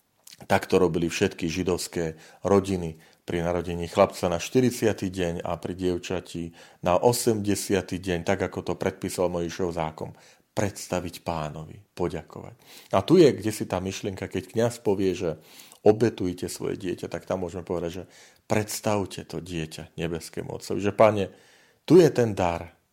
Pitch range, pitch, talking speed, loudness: 85-100 Hz, 90 Hz, 150 wpm, -26 LUFS